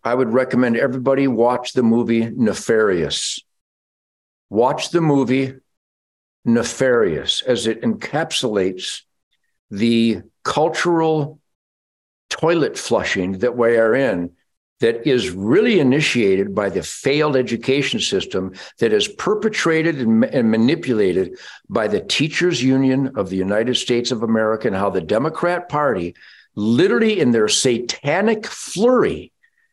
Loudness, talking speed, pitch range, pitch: -18 LUFS, 115 wpm, 115-170 Hz, 130 Hz